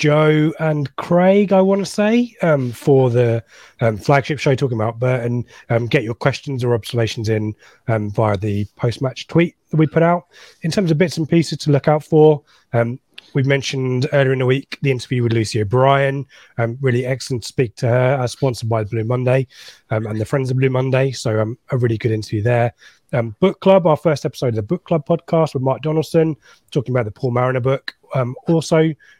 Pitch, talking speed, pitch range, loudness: 130 Hz, 215 wpm, 120-155 Hz, -18 LUFS